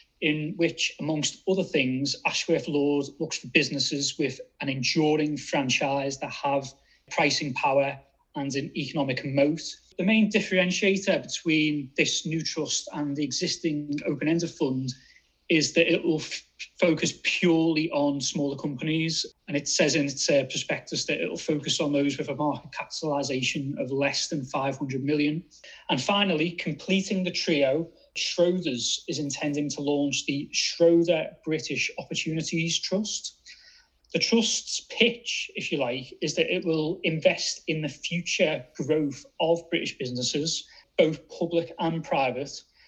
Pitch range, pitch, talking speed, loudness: 140-170 Hz, 155 Hz, 145 wpm, -26 LUFS